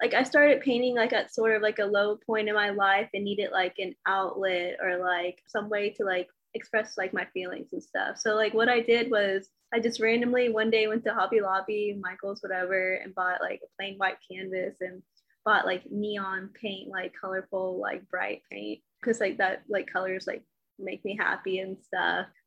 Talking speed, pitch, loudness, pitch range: 205 wpm, 200 Hz, -28 LUFS, 185-220 Hz